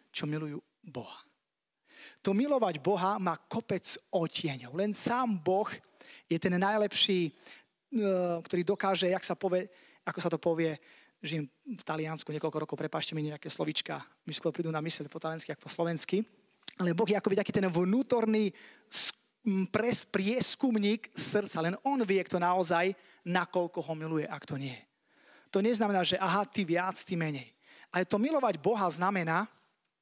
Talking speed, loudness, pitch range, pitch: 155 wpm, -31 LUFS, 165-205 Hz, 185 Hz